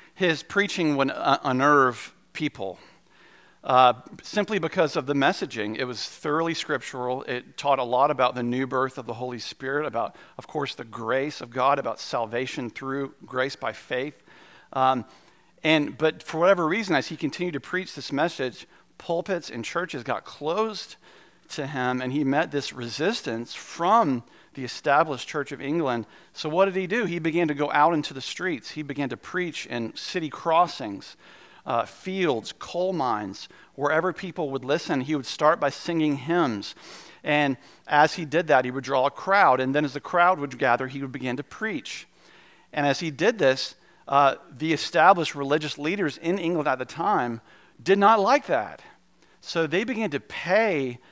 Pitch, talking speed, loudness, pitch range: 145 Hz, 180 wpm, -25 LUFS, 130-170 Hz